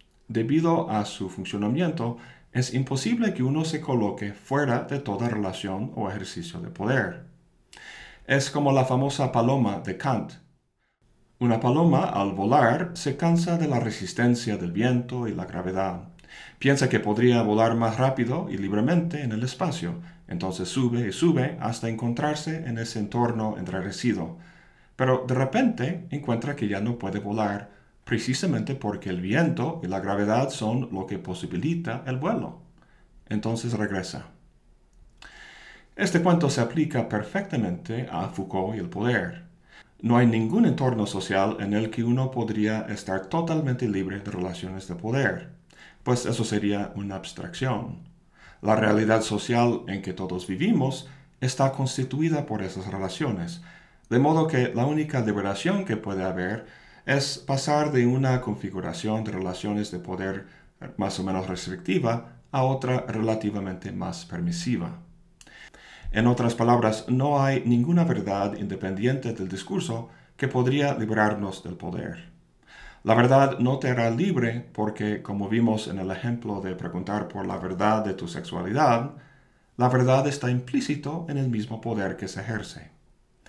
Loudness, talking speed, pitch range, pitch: -26 LUFS, 145 wpm, 100-135 Hz, 115 Hz